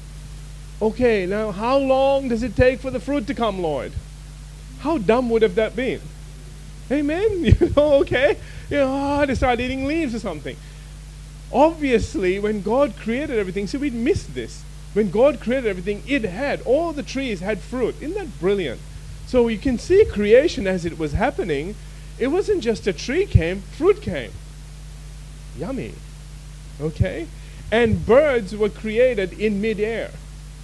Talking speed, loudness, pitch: 155 wpm, -21 LUFS, 215 Hz